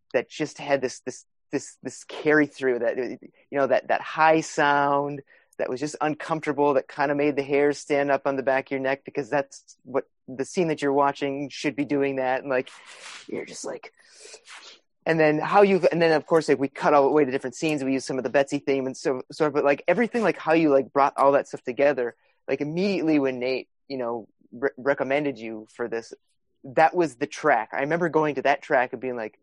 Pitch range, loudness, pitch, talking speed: 135-150 Hz, -24 LUFS, 140 Hz, 230 wpm